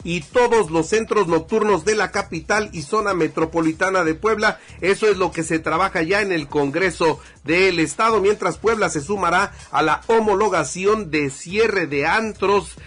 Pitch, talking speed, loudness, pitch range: 190 Hz, 170 wpm, -19 LUFS, 165-215 Hz